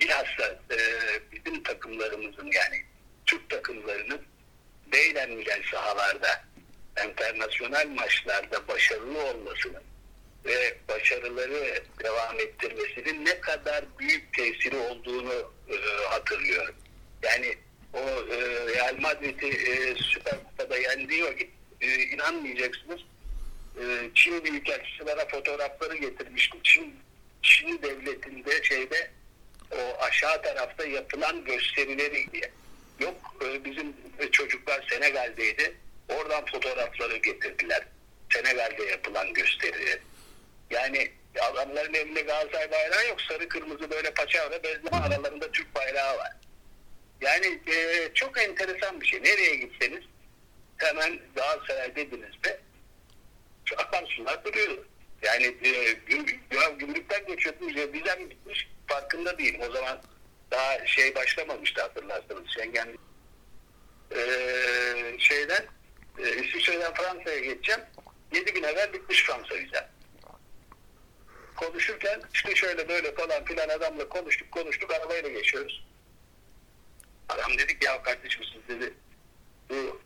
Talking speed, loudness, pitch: 105 wpm, -27 LUFS, 270 Hz